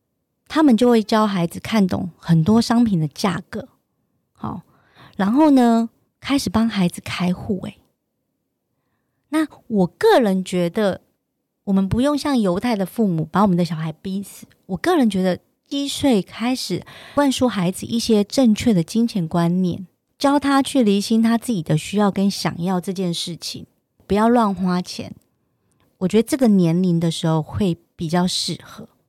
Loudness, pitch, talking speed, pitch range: -19 LUFS, 200 Hz, 230 characters per minute, 180-235 Hz